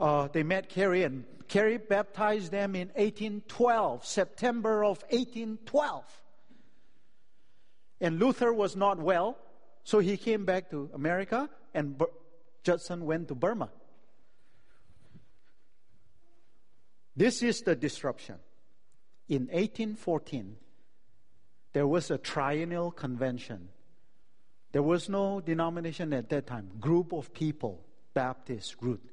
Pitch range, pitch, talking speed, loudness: 145-205 Hz, 175 Hz, 110 wpm, -31 LUFS